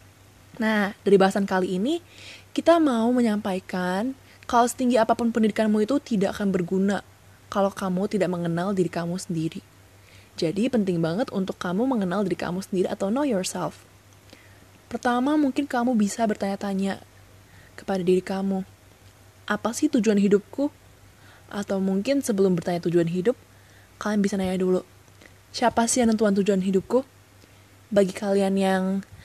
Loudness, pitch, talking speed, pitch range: -24 LUFS, 195 Hz, 135 wpm, 175-220 Hz